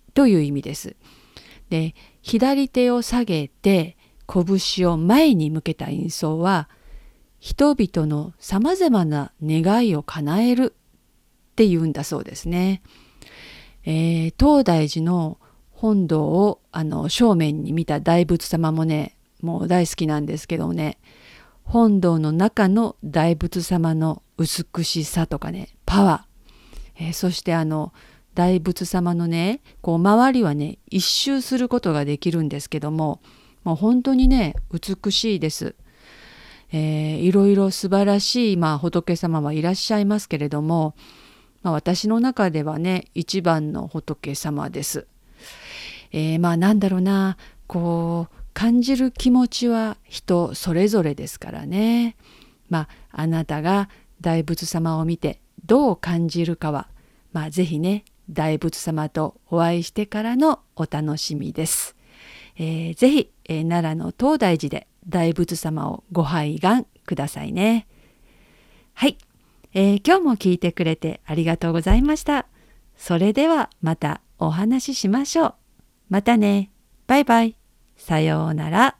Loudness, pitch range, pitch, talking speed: -21 LUFS, 160-210 Hz, 175 Hz, 250 characters per minute